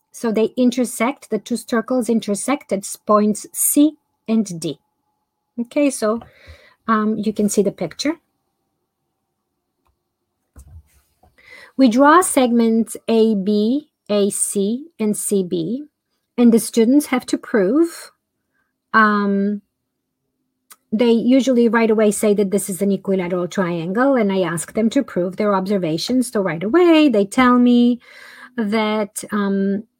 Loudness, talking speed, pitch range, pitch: -18 LUFS, 120 wpm, 200-255 Hz, 220 Hz